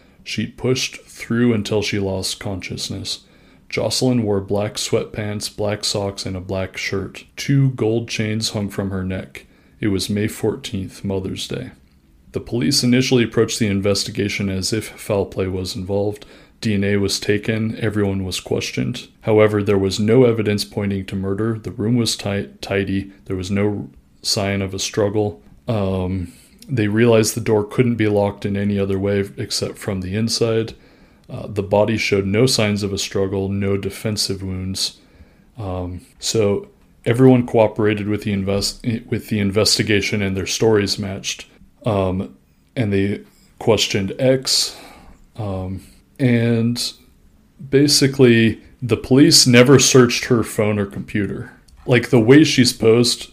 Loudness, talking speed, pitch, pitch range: -18 LUFS, 145 wpm, 105 Hz, 95-115 Hz